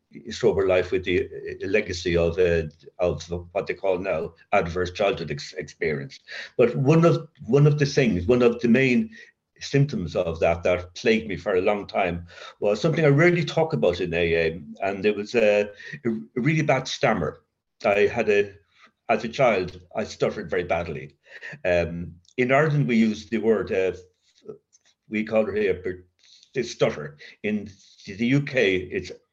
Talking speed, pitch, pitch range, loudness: 165 wpm, 110 Hz, 90-150 Hz, -23 LUFS